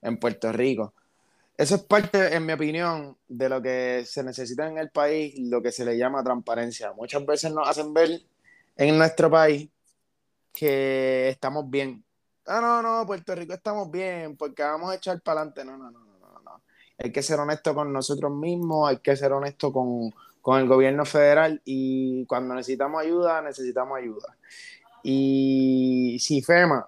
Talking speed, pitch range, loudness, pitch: 175 wpm, 130-160 Hz, -24 LUFS, 145 Hz